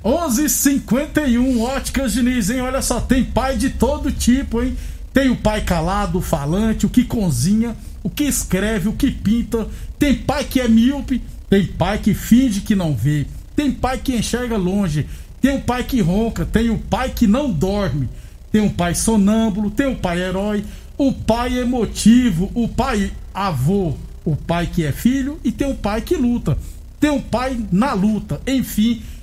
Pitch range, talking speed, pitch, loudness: 195-255 Hz, 180 wpm, 225 Hz, -18 LUFS